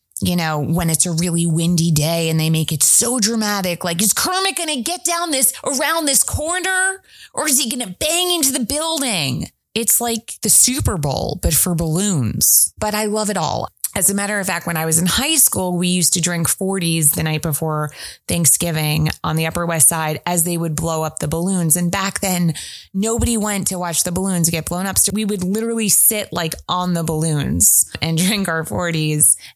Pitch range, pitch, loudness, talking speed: 160-220 Hz, 180 Hz, -16 LUFS, 205 wpm